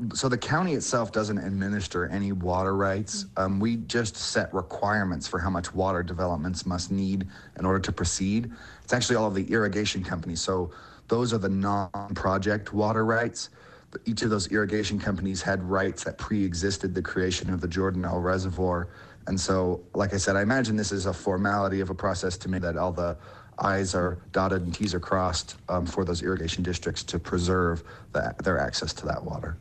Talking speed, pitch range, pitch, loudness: 190 wpm, 90-100 Hz, 95 Hz, -28 LUFS